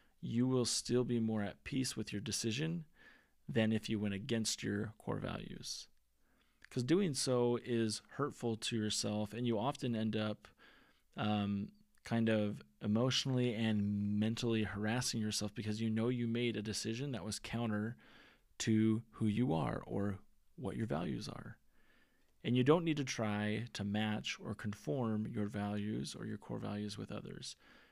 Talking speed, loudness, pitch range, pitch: 160 wpm, -38 LUFS, 105-120 Hz, 110 Hz